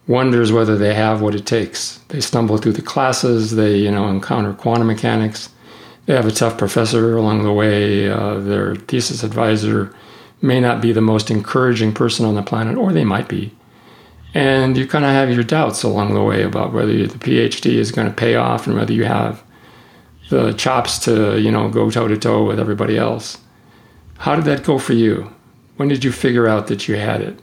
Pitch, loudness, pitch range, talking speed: 115 Hz, -16 LUFS, 105-120 Hz, 205 wpm